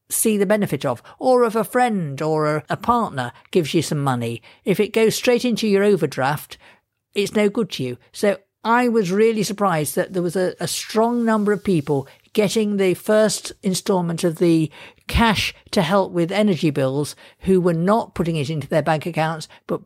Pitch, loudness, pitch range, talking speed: 190 Hz, -20 LUFS, 155-215 Hz, 195 wpm